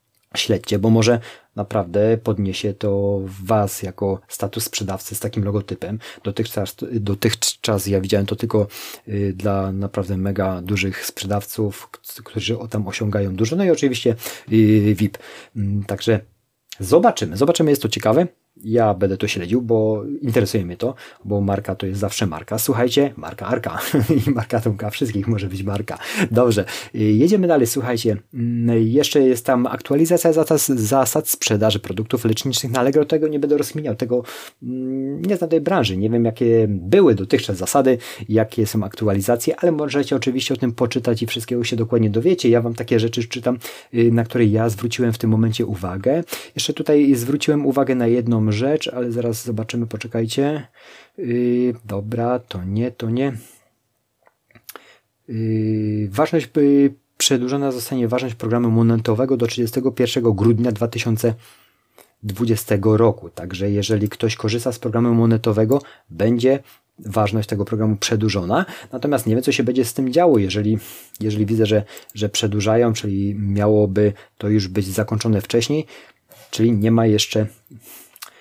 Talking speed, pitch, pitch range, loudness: 145 wpm, 115 Hz, 105-125 Hz, -19 LUFS